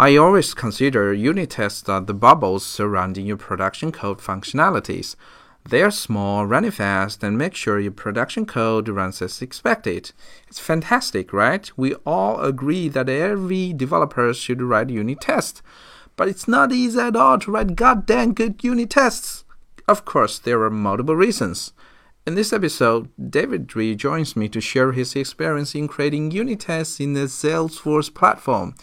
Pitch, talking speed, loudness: 135 Hz, 160 wpm, -20 LUFS